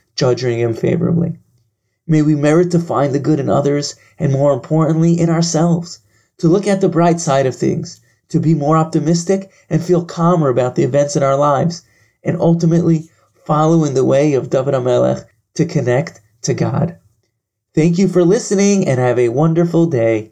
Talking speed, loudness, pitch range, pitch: 175 wpm, -15 LUFS, 130-170 Hz, 155 Hz